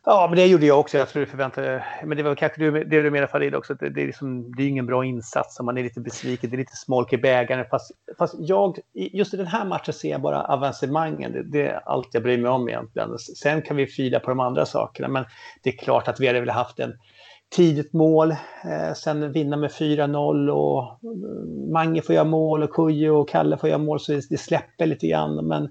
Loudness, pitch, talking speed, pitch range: -23 LUFS, 140 Hz, 235 wpm, 125-155 Hz